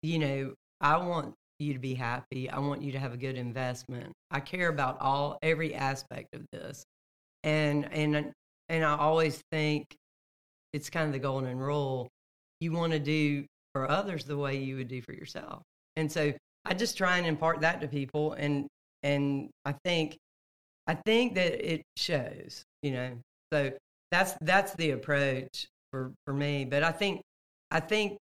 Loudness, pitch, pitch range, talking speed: -31 LUFS, 145 Hz, 135-160 Hz, 175 wpm